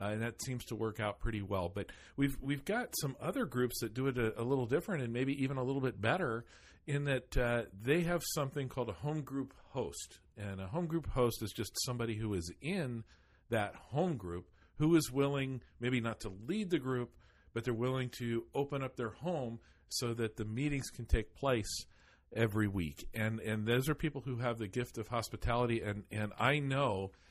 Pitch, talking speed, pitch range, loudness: 120 Hz, 210 wpm, 110-140 Hz, -37 LUFS